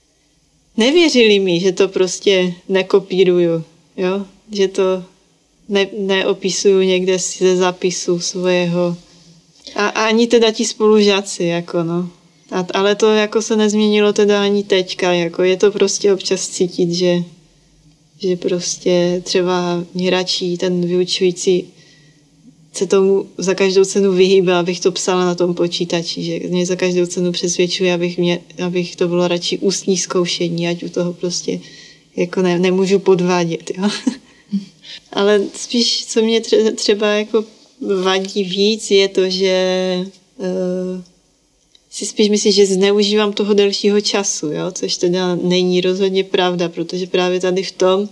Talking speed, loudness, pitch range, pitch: 140 wpm, -16 LUFS, 175-200 Hz, 185 Hz